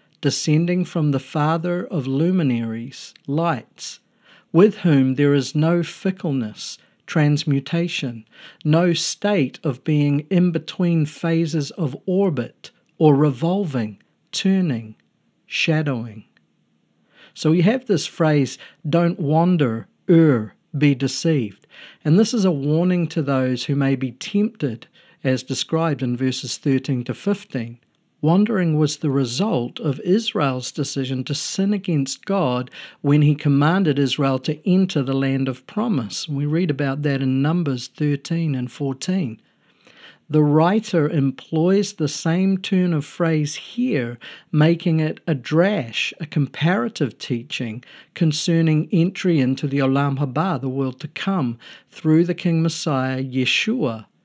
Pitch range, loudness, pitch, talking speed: 135-175 Hz, -20 LUFS, 155 Hz, 130 wpm